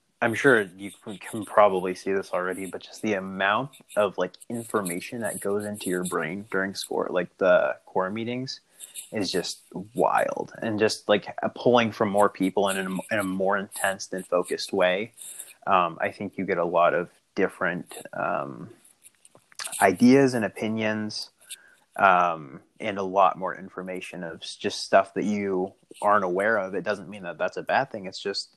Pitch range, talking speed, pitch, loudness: 95-110 Hz, 170 wpm, 100 Hz, -26 LUFS